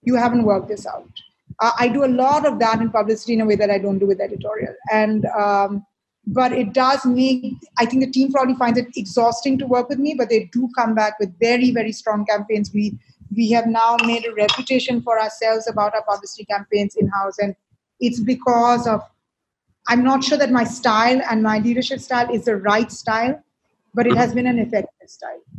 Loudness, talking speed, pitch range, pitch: -19 LUFS, 215 wpm, 215-245 Hz, 230 Hz